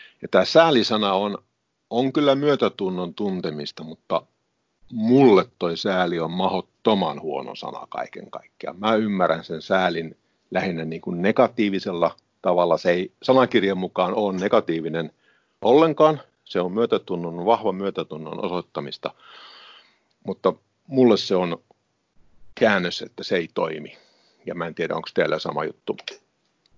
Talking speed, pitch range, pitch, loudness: 125 wpm, 85-120 Hz, 95 Hz, -22 LUFS